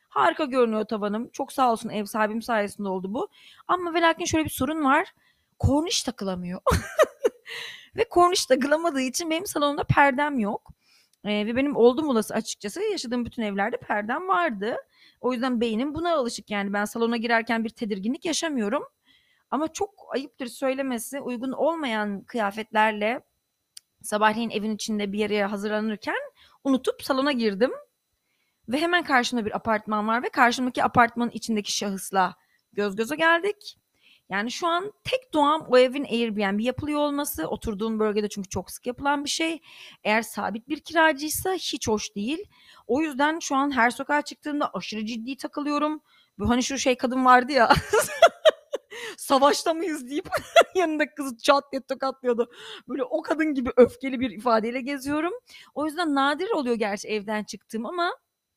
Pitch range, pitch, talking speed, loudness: 220-305 Hz, 260 Hz, 150 wpm, -25 LUFS